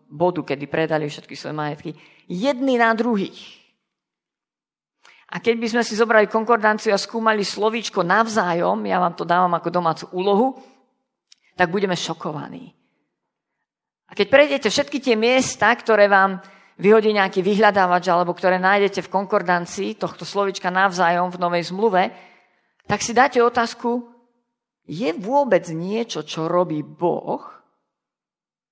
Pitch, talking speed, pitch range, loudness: 195 Hz, 130 wpm, 175-230 Hz, -20 LUFS